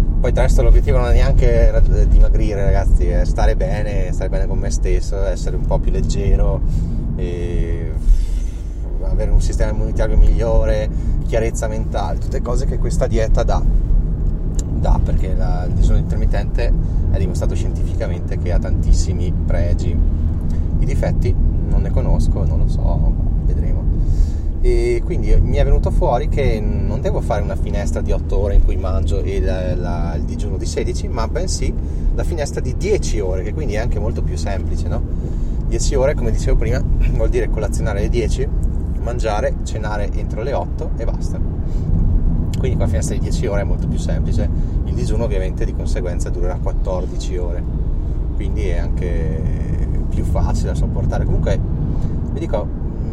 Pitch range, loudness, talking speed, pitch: 75-85 Hz, -20 LUFS, 160 wpm, 80 Hz